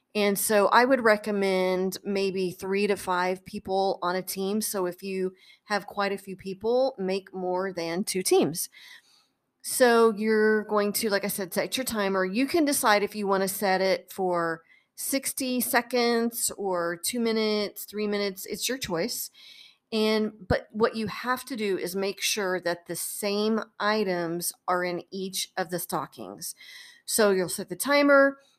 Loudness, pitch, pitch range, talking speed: -26 LUFS, 200 Hz, 185-225 Hz, 170 wpm